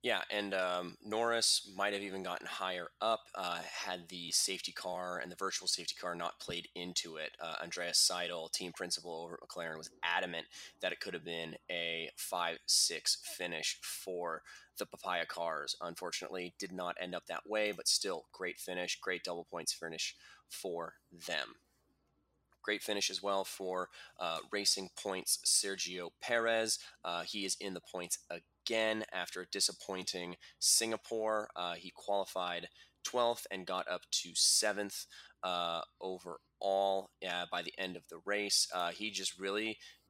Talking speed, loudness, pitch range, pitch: 155 wpm, -36 LUFS, 90-105 Hz, 95 Hz